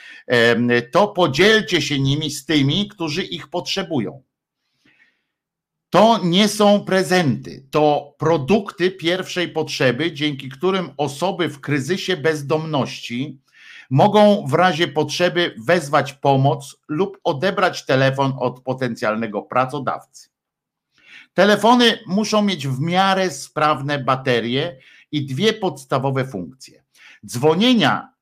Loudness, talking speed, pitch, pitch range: -18 LUFS, 100 wpm, 155 Hz, 140-185 Hz